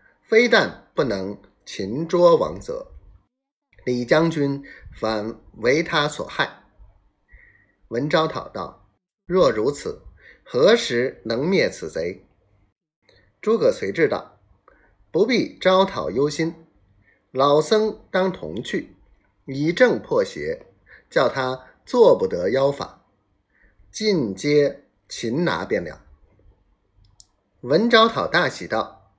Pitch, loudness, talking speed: 165 Hz, -21 LUFS, 140 characters per minute